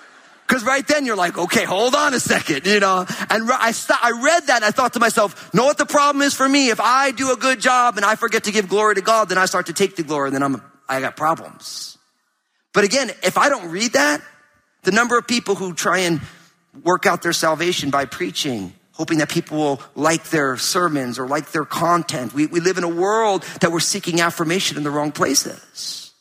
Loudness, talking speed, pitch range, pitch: -18 LUFS, 235 wpm, 160-235 Hz, 185 Hz